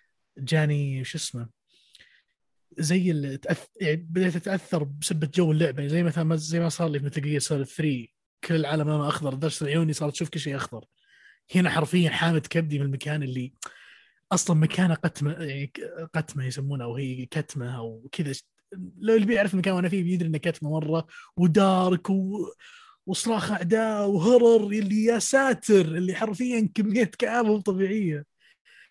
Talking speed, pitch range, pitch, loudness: 155 wpm, 150-195 Hz, 165 Hz, -25 LUFS